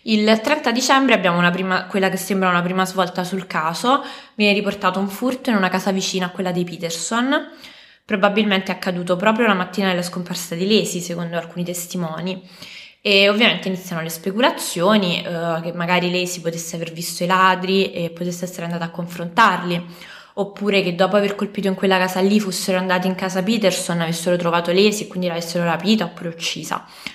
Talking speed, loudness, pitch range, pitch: 180 wpm, -19 LUFS, 175-205 Hz, 185 Hz